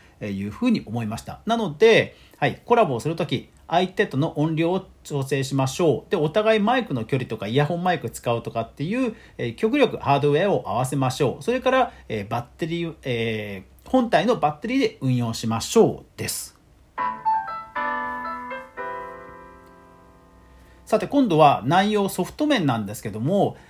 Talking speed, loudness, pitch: 330 characters per minute, -23 LUFS, 145 Hz